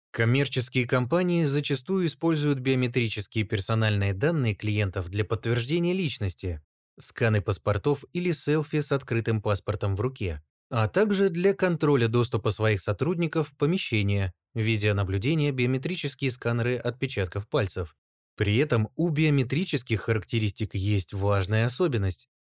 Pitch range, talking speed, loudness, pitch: 105-145 Hz, 110 wpm, -26 LUFS, 115 Hz